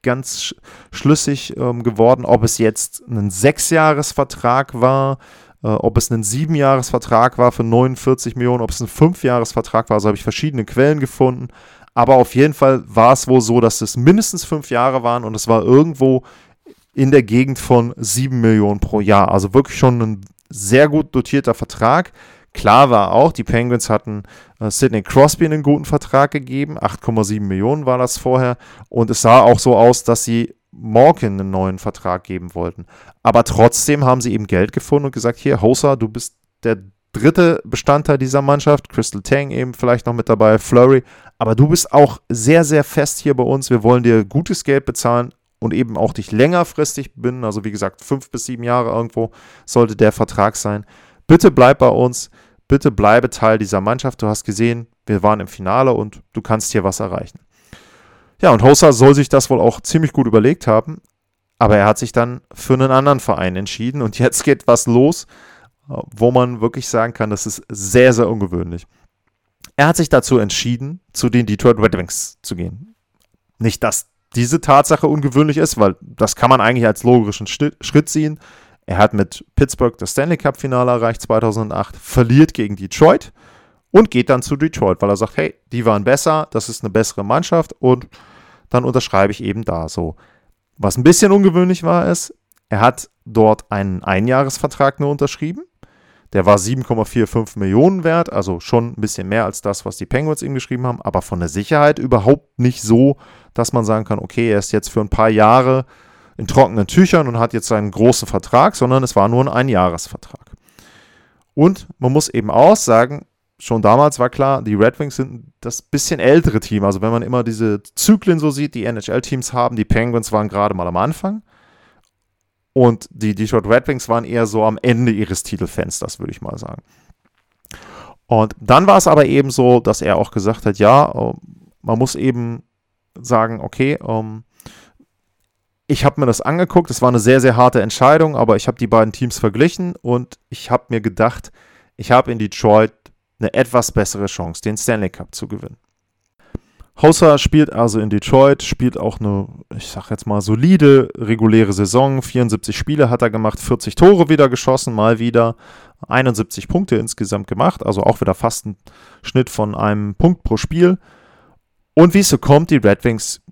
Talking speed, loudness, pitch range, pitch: 185 wpm, -14 LUFS, 110-135 Hz, 120 Hz